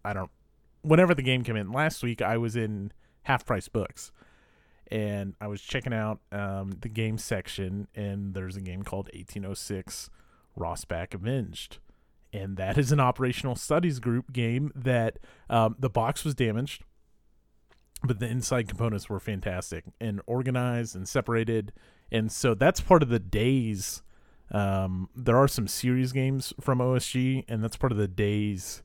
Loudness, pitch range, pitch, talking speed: -28 LUFS, 100-125 Hz, 115 Hz, 160 wpm